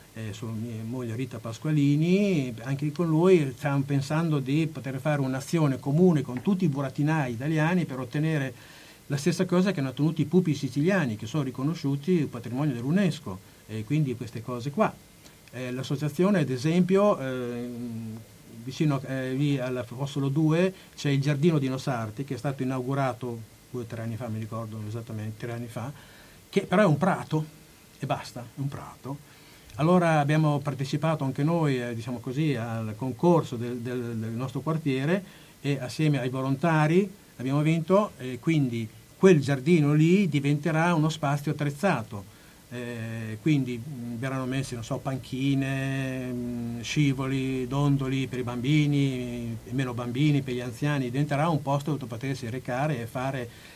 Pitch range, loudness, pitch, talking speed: 125-155 Hz, -27 LUFS, 140 Hz, 150 wpm